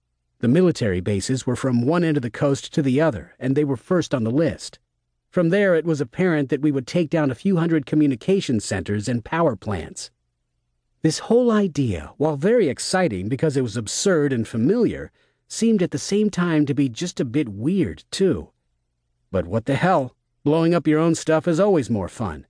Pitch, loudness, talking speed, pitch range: 145 Hz, -21 LUFS, 200 wpm, 115-170 Hz